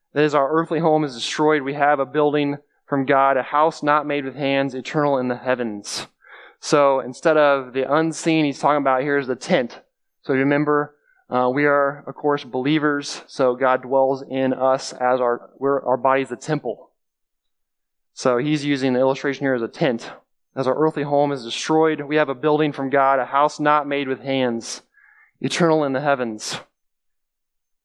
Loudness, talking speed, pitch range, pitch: -20 LUFS, 185 wpm, 130-150 Hz, 140 Hz